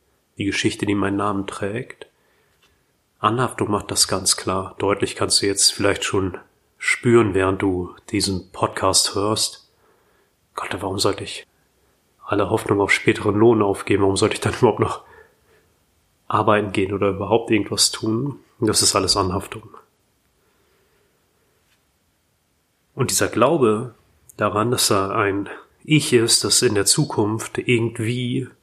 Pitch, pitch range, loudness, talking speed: 105 Hz, 100-115 Hz, -19 LUFS, 130 wpm